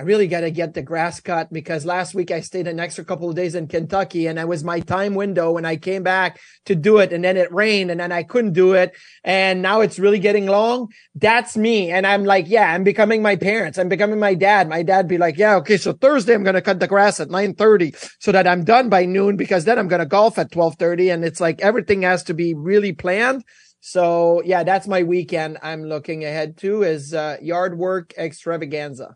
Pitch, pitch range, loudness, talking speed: 185 Hz, 170-200 Hz, -18 LUFS, 235 wpm